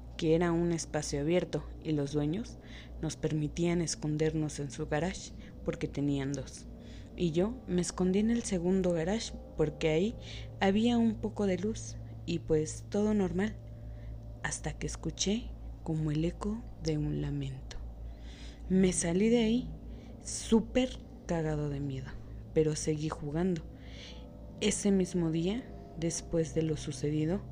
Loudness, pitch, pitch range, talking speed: -32 LUFS, 160 Hz, 145-180 Hz, 135 wpm